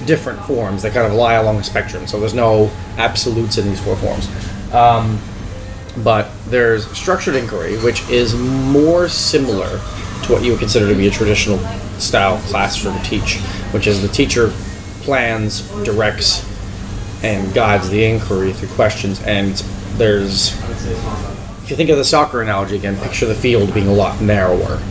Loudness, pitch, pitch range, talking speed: -16 LUFS, 105 Hz, 100-115 Hz, 160 wpm